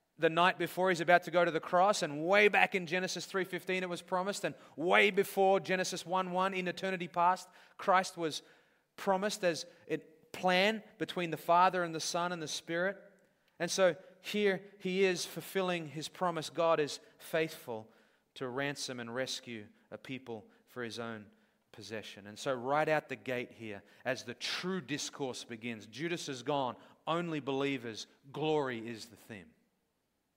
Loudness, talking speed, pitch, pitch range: -33 LUFS, 165 wpm, 170 Hz, 140-185 Hz